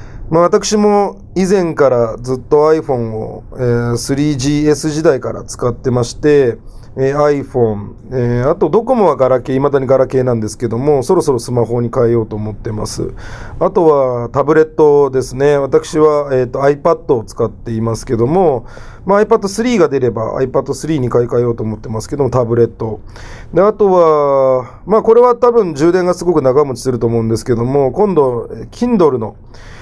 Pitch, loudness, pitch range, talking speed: 130 Hz, -13 LUFS, 115-155 Hz, 355 characters per minute